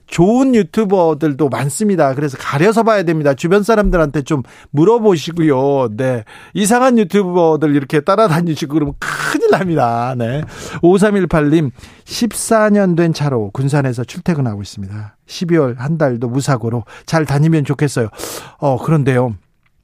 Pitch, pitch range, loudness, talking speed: 155 Hz, 135-185 Hz, -14 LUFS, 305 characters per minute